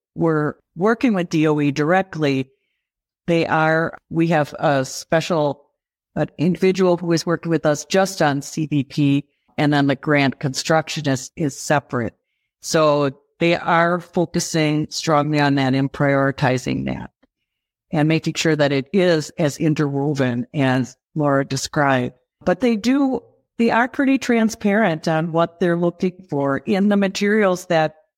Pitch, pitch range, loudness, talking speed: 155 Hz, 140-175 Hz, -19 LUFS, 140 wpm